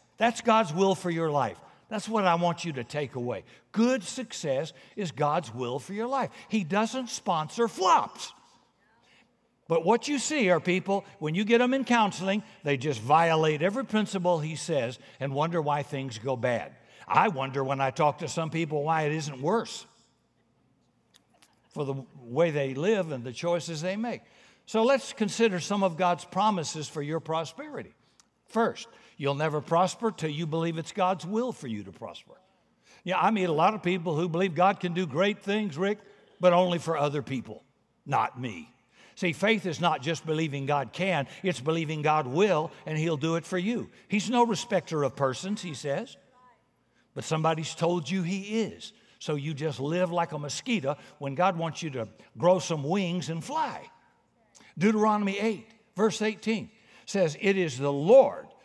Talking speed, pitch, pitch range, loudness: 180 wpm, 175 Hz, 150-215 Hz, -28 LUFS